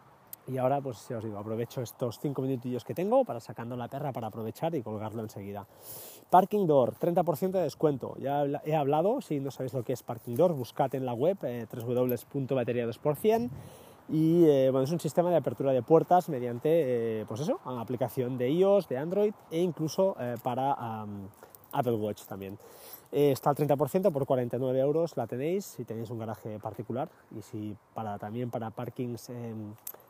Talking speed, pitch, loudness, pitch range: 185 wpm, 130 Hz, -30 LUFS, 115-155 Hz